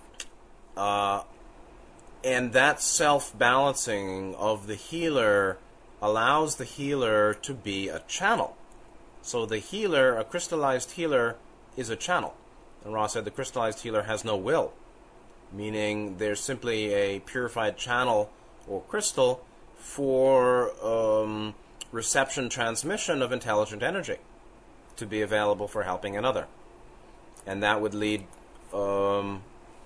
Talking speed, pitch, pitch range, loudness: 115 wpm, 110 Hz, 105-130 Hz, -27 LUFS